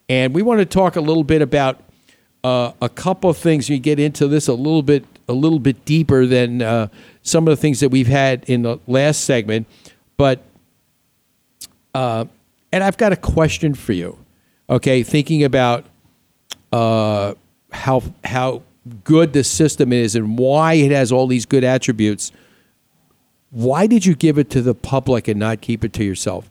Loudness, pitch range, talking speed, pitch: -17 LUFS, 120-150 Hz, 180 wpm, 130 Hz